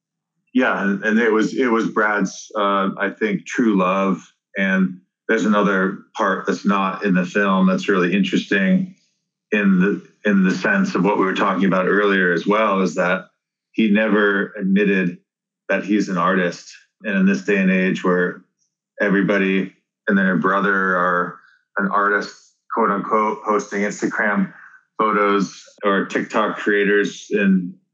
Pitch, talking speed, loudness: 100 Hz, 150 wpm, -19 LUFS